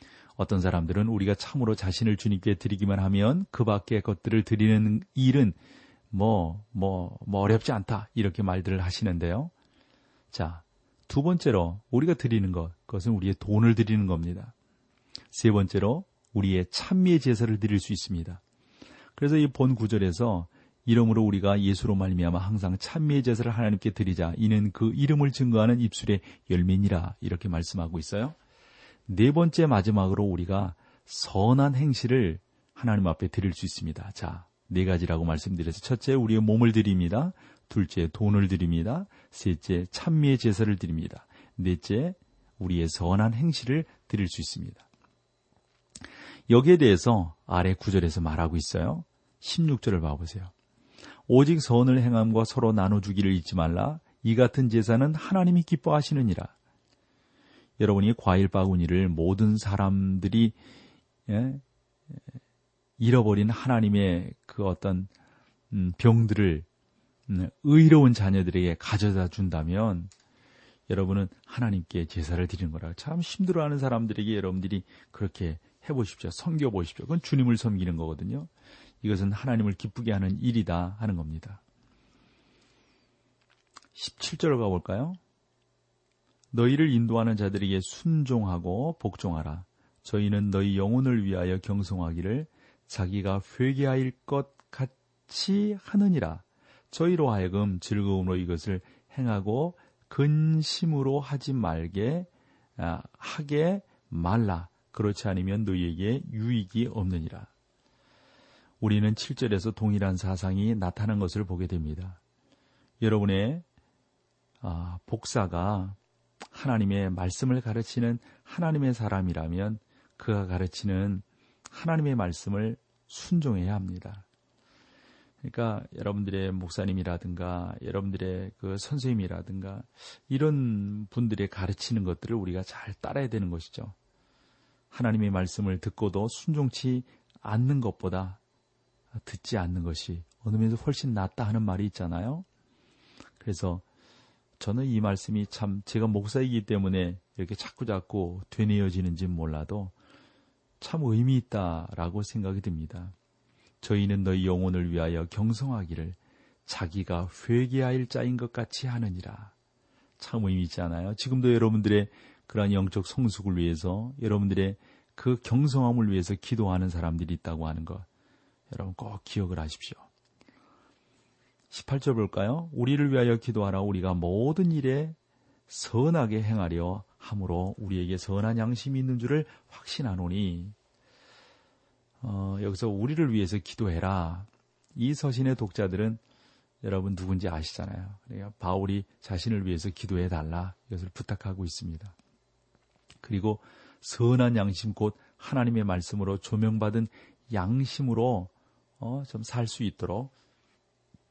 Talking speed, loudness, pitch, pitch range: 295 characters per minute, -28 LUFS, 105 Hz, 95-125 Hz